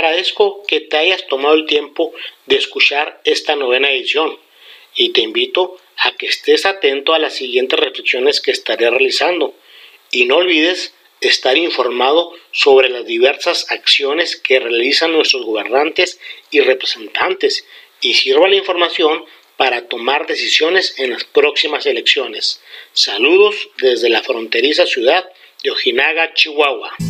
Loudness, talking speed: -14 LUFS, 135 wpm